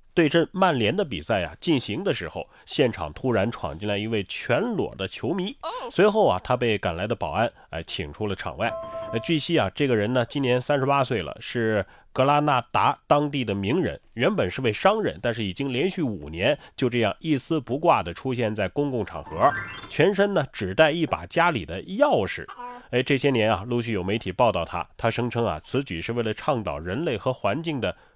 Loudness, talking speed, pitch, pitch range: -25 LUFS, 300 characters per minute, 120 Hz, 105-145 Hz